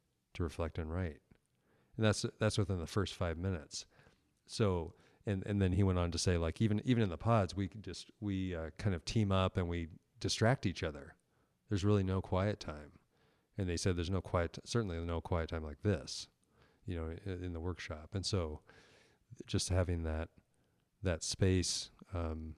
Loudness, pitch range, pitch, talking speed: -37 LUFS, 85-105 Hz, 95 Hz, 195 wpm